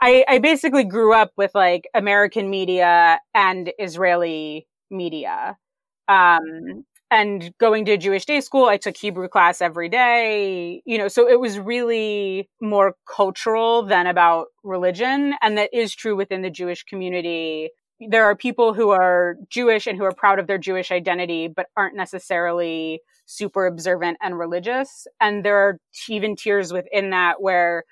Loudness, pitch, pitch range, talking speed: -19 LUFS, 200 Hz, 180-225 Hz, 155 wpm